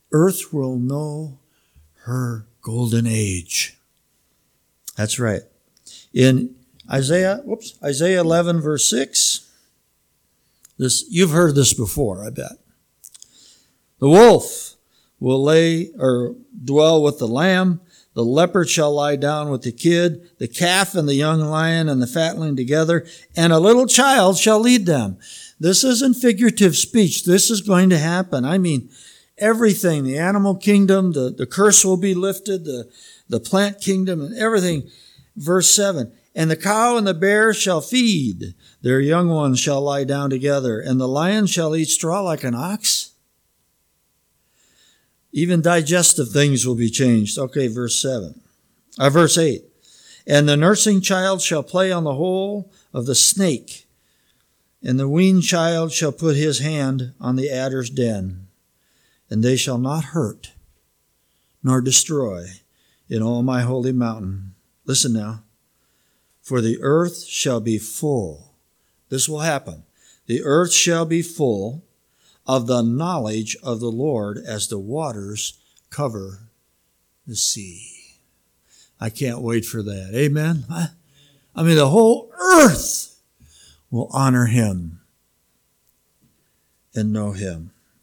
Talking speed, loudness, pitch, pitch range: 135 wpm, -18 LUFS, 145 Hz, 120-175 Hz